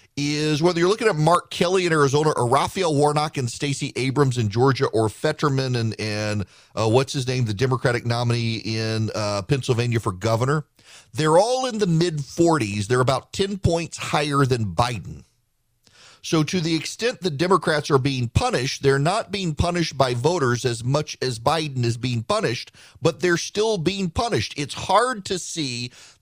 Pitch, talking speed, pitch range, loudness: 140 Hz, 175 wpm, 120-160 Hz, -22 LUFS